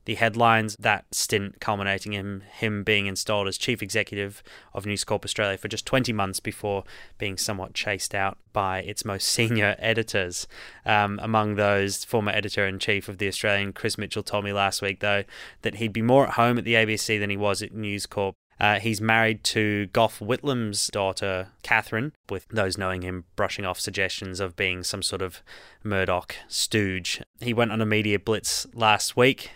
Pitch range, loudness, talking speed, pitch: 100-110 Hz, -25 LUFS, 185 wpm, 105 Hz